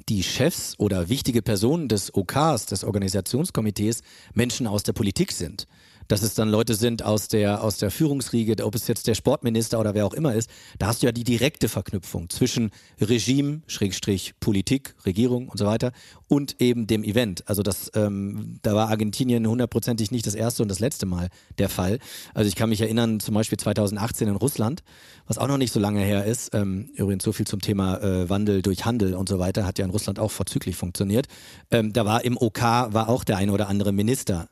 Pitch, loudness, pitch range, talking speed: 110 Hz, -24 LUFS, 100-120 Hz, 205 wpm